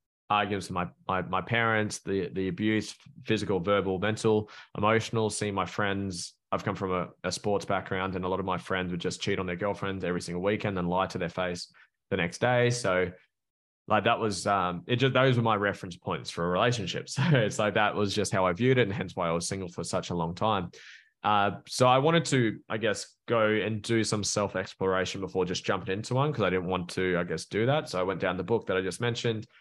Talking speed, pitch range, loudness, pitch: 240 wpm, 95-110 Hz, -29 LUFS, 100 Hz